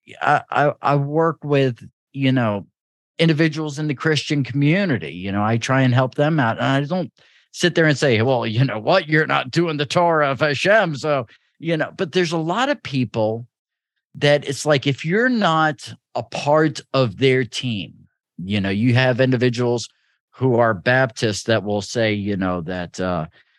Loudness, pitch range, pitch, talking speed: -19 LUFS, 115-155 Hz, 135 Hz, 185 wpm